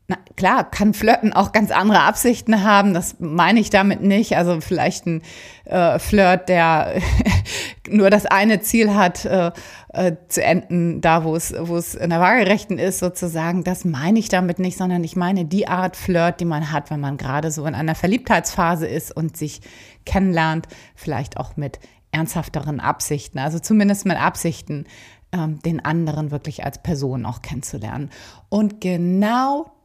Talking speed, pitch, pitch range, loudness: 165 wpm, 175 Hz, 155-195 Hz, -19 LUFS